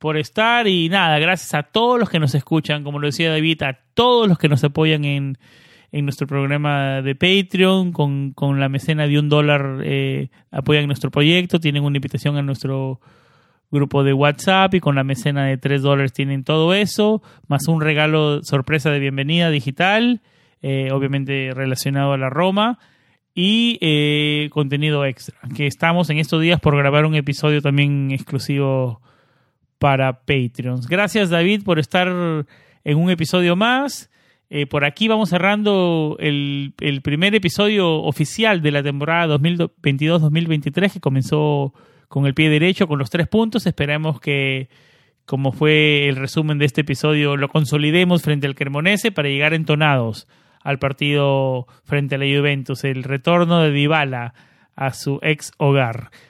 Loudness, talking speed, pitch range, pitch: -18 LUFS, 160 wpm, 140-165 Hz, 150 Hz